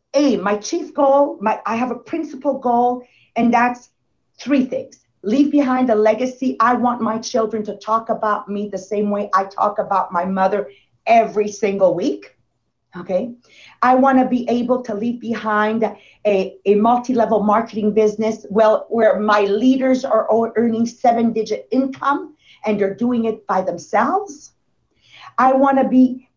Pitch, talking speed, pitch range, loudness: 225 Hz, 160 wpm, 210-255 Hz, -18 LUFS